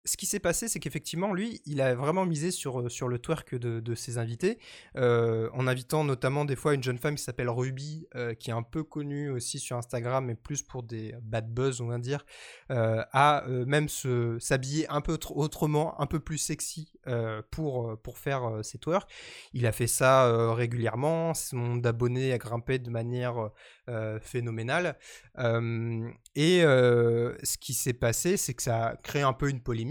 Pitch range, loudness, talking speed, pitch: 120-150 Hz, -29 LUFS, 200 wpm, 130 Hz